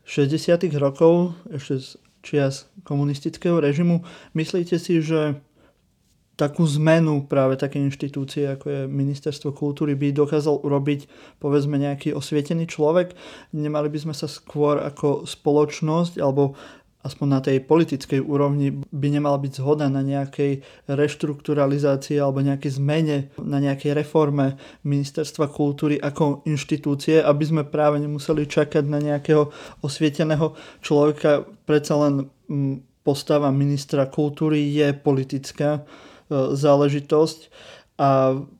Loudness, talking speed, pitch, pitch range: -22 LUFS, 120 wpm, 145 Hz, 140-155 Hz